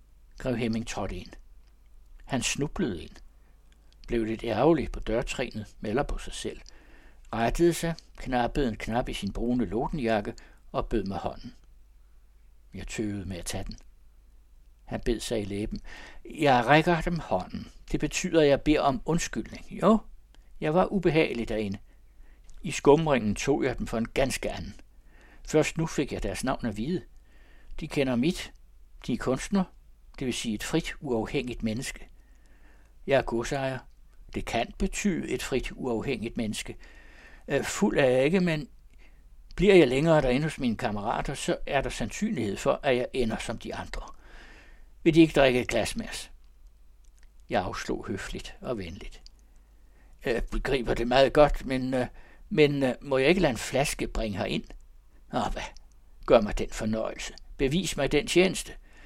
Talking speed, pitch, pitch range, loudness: 160 wpm, 120 Hz, 95-150 Hz, -28 LUFS